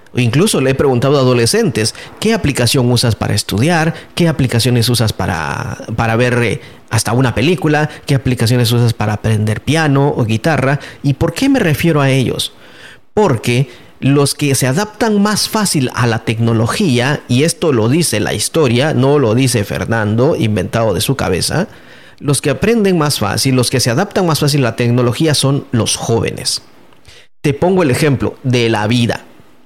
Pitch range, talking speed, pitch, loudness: 115-150 Hz, 170 wpm, 125 Hz, -13 LUFS